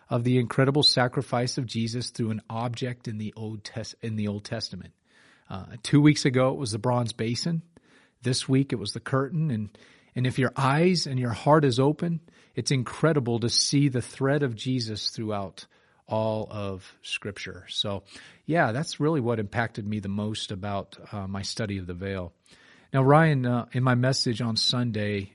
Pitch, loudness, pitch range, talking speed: 120 Hz, -26 LUFS, 105-135 Hz, 185 wpm